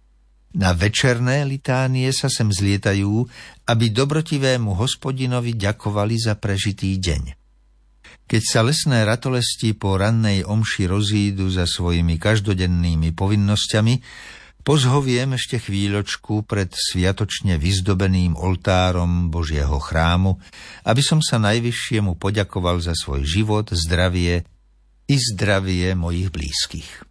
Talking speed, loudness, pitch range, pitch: 105 wpm, -20 LUFS, 90-115 Hz, 100 Hz